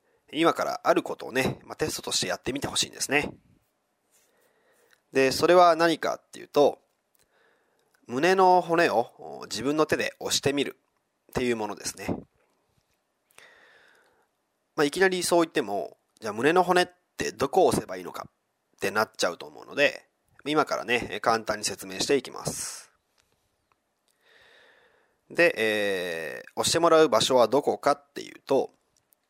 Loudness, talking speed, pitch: -25 LUFS, 285 characters per minute, 175 Hz